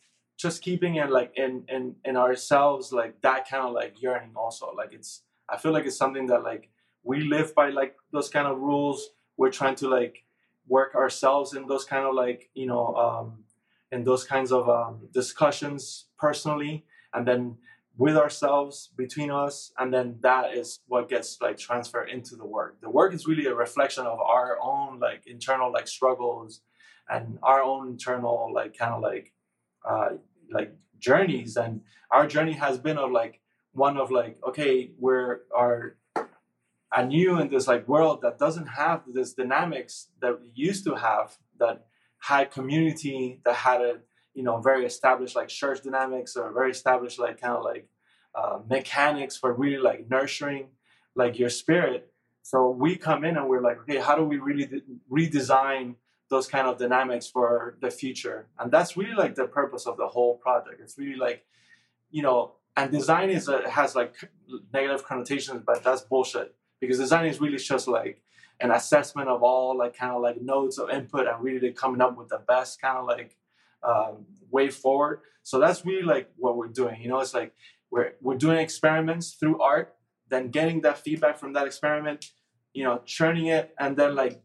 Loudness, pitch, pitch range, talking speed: -26 LUFS, 130 Hz, 125-145 Hz, 185 wpm